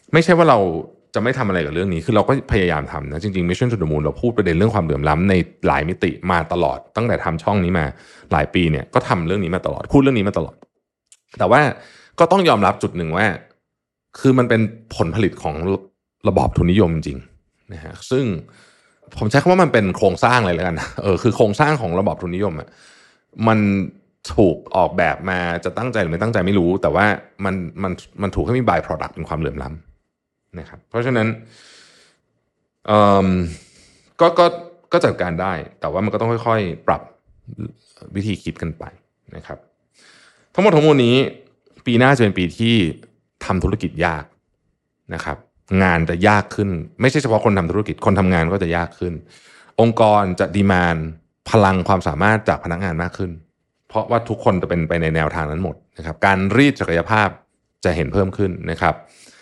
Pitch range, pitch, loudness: 85-110 Hz, 95 Hz, -18 LUFS